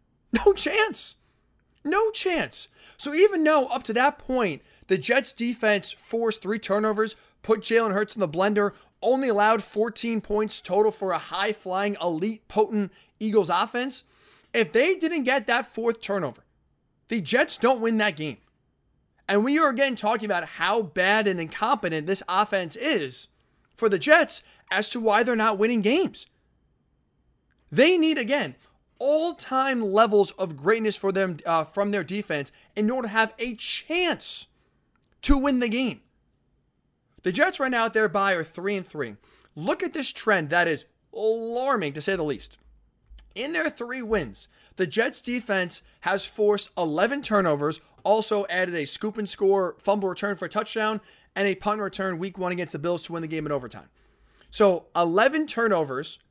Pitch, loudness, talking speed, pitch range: 215 Hz, -25 LUFS, 170 wpm, 190-245 Hz